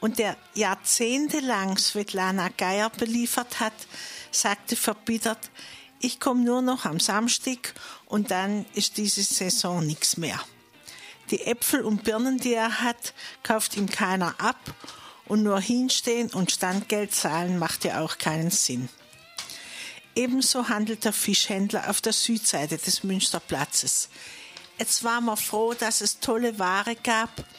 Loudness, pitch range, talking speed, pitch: -25 LUFS, 195-235 Hz, 135 wpm, 220 Hz